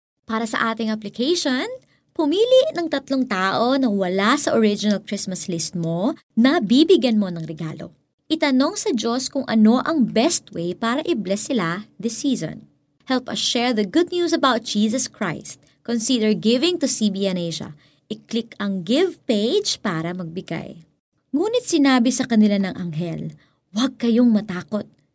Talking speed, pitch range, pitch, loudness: 150 wpm, 195-275 Hz, 230 Hz, -20 LUFS